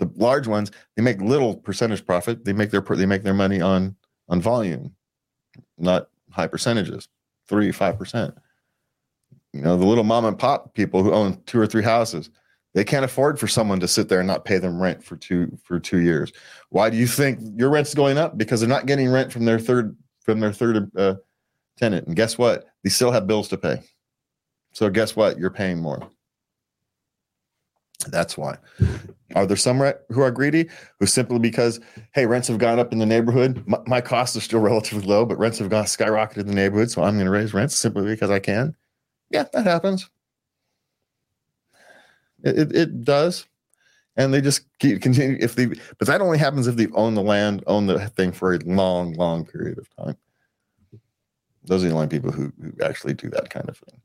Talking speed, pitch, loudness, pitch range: 200 wpm, 110 Hz, -21 LUFS, 95-125 Hz